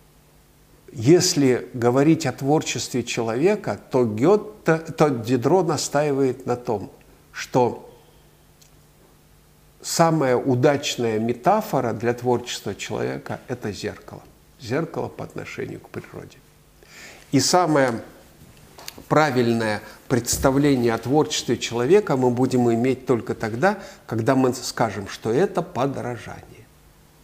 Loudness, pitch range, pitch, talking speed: -22 LUFS, 120-150 Hz, 130 Hz, 95 wpm